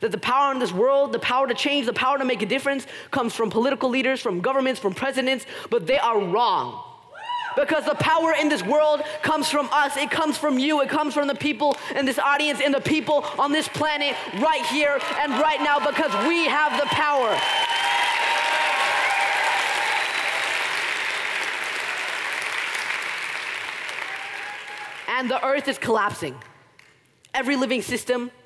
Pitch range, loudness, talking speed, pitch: 265-305 Hz, -22 LUFS, 155 wpm, 285 Hz